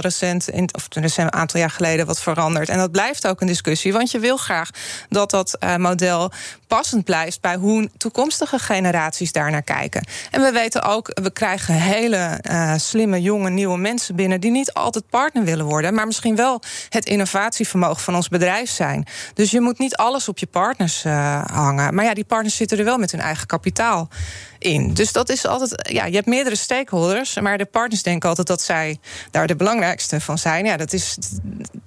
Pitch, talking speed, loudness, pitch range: 190 Hz, 190 wpm, -19 LUFS, 165-225 Hz